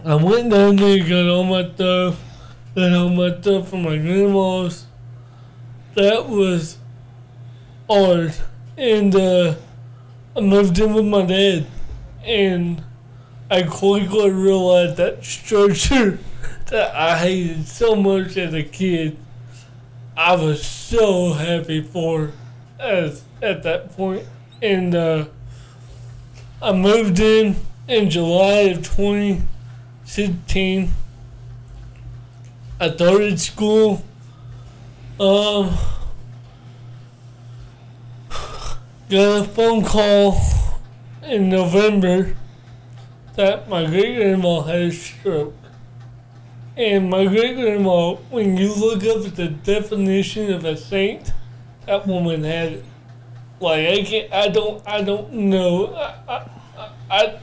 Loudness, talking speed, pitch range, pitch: -18 LUFS, 110 wpm, 120-195 Hz, 170 Hz